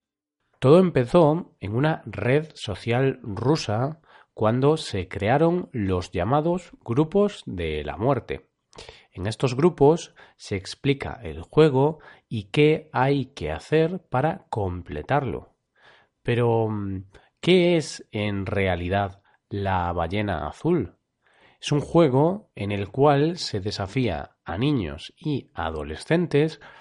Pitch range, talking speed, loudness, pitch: 100-155 Hz, 110 wpm, -24 LUFS, 125 Hz